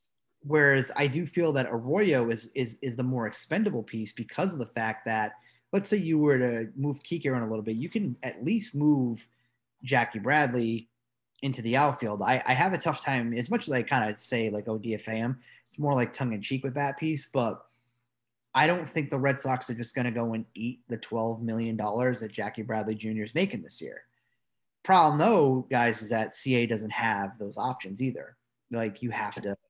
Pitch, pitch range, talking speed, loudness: 120 Hz, 115-140 Hz, 210 wpm, -28 LUFS